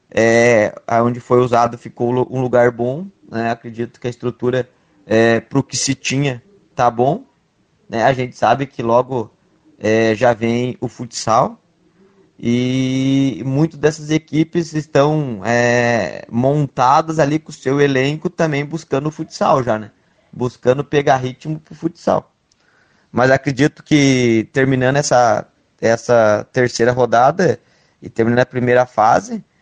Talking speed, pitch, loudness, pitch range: 140 wpm, 130 Hz, -16 LUFS, 120-150 Hz